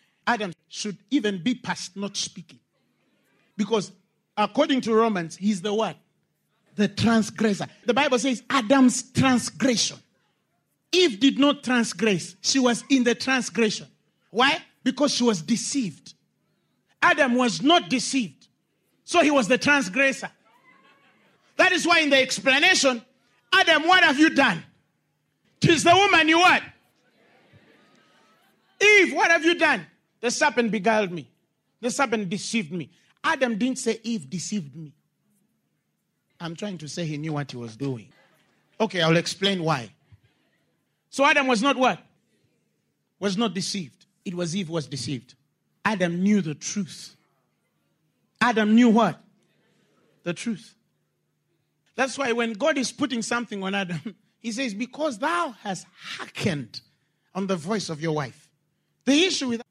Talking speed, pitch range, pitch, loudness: 140 wpm, 180-265 Hz, 220 Hz, -22 LUFS